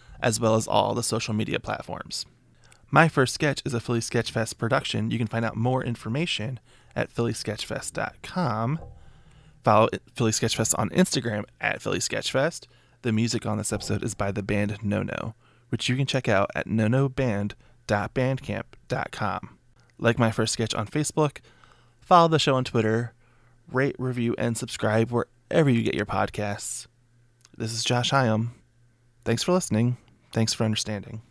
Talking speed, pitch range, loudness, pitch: 155 wpm, 110-125 Hz, -26 LUFS, 120 Hz